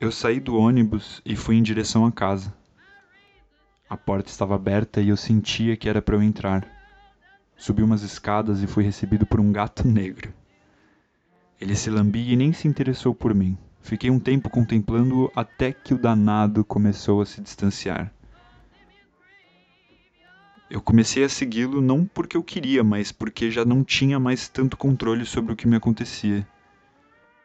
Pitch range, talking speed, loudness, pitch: 105-130 Hz, 160 wpm, -22 LUFS, 110 Hz